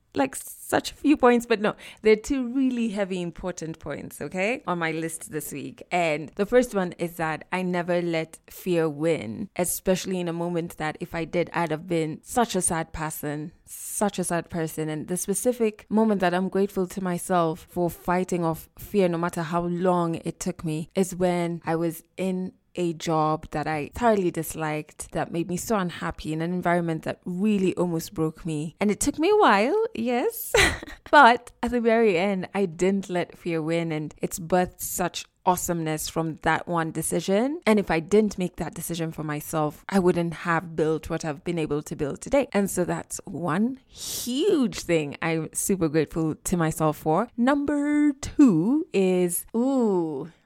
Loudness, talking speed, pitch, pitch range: -25 LUFS, 185 wpm, 175 Hz, 160-200 Hz